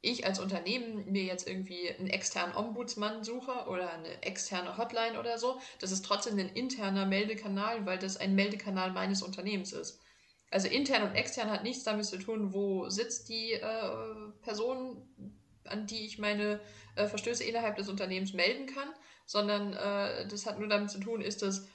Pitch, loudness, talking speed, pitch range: 210 Hz, -35 LUFS, 175 wpm, 195-230 Hz